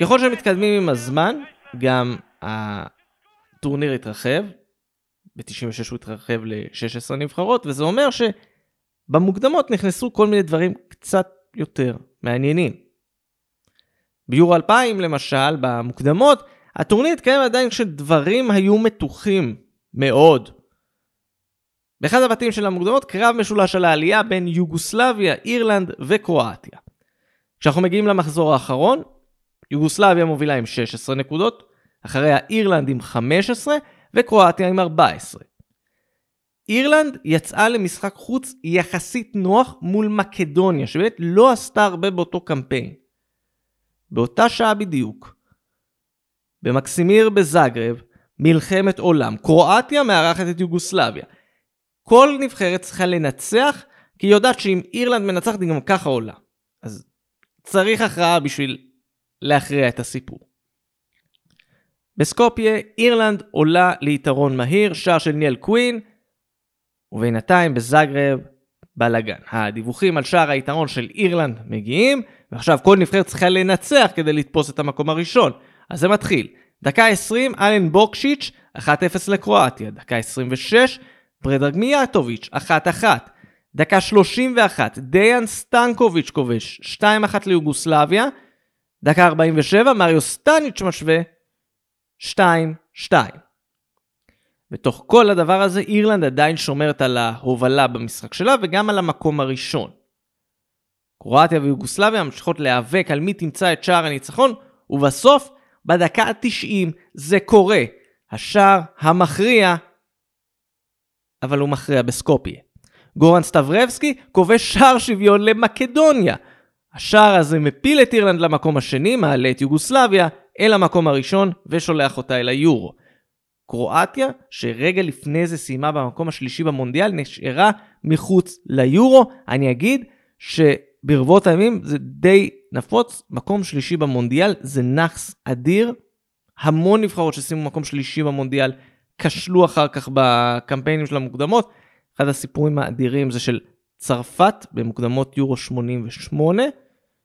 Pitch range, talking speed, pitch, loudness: 140-210 Hz, 110 wpm, 170 Hz, -17 LUFS